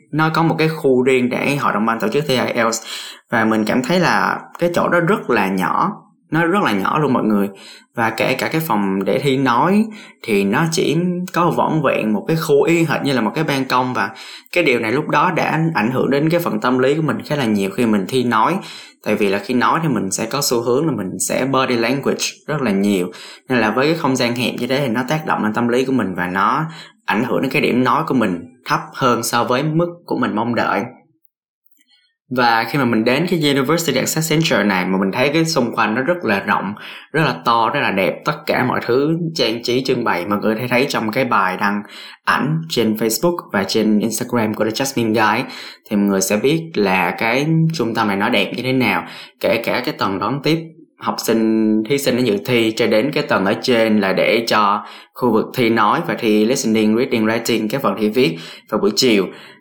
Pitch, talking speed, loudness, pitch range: 125 Hz, 245 wpm, -17 LUFS, 110-155 Hz